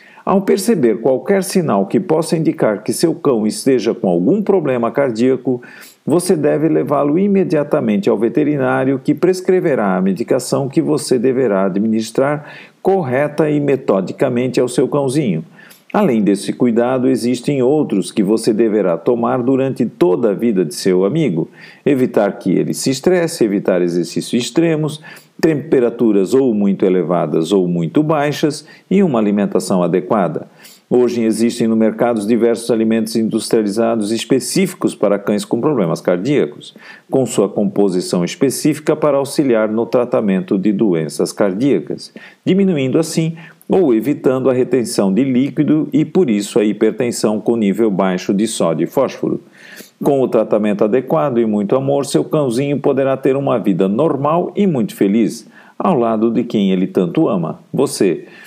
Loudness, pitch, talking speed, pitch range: -15 LUFS, 130 Hz, 145 wpm, 110-155 Hz